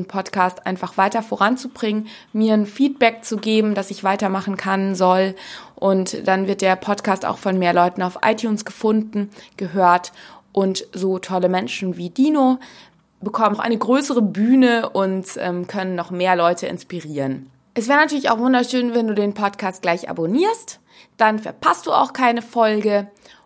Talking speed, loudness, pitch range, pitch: 155 wpm, -19 LUFS, 185-230 Hz, 200 Hz